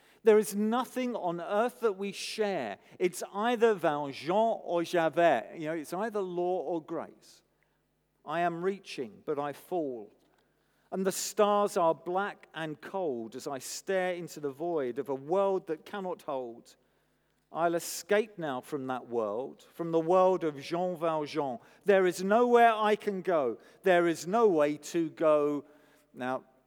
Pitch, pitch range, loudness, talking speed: 175 Hz, 155-200 Hz, -30 LUFS, 160 wpm